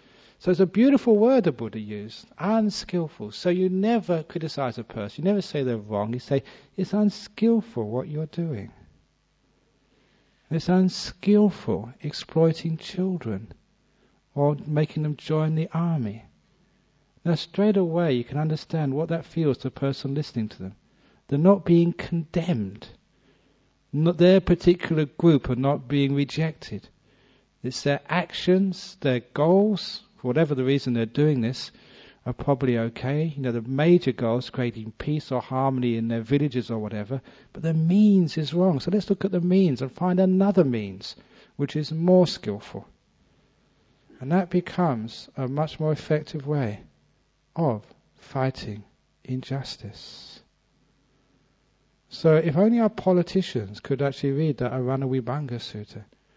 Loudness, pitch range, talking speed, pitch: -24 LUFS, 125-180 Hz, 145 wpm, 150 Hz